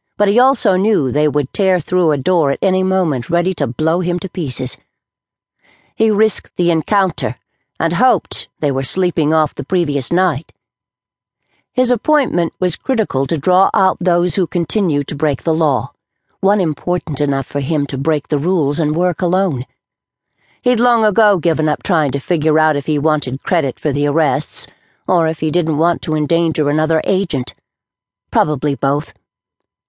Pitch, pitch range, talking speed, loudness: 160 Hz, 145-185 Hz, 170 wpm, -16 LUFS